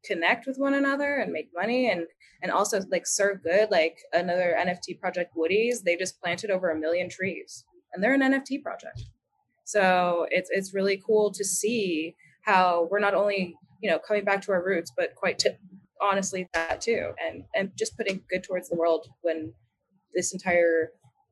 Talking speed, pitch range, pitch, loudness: 180 wpm, 175-215 Hz, 190 Hz, -26 LUFS